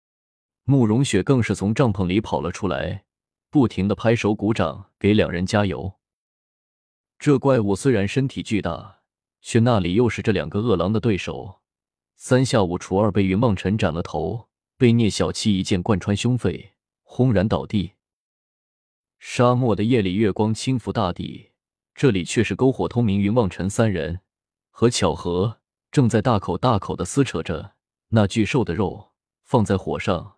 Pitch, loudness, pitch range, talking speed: 105 Hz, -21 LUFS, 95-115 Hz, 235 characters per minute